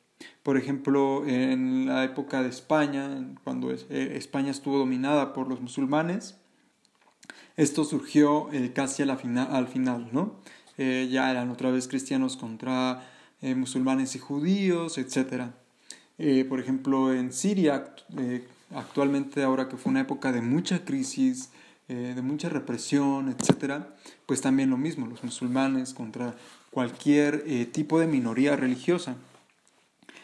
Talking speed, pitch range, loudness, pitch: 115 wpm, 130-150 Hz, -28 LUFS, 135 Hz